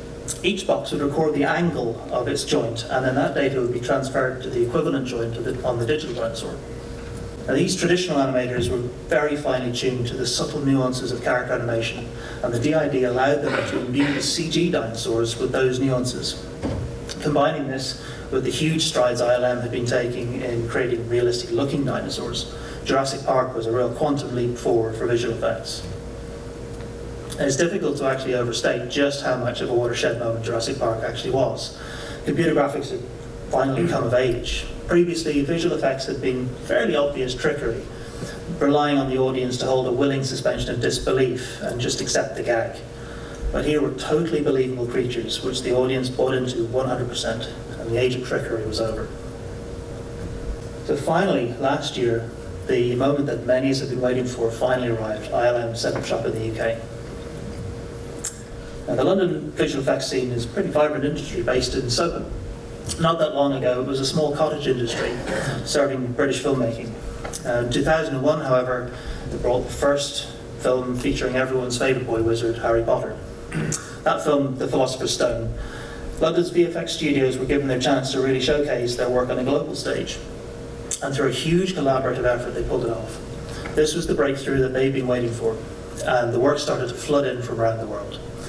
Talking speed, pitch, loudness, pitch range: 180 wpm, 125 Hz, -23 LUFS, 120-140 Hz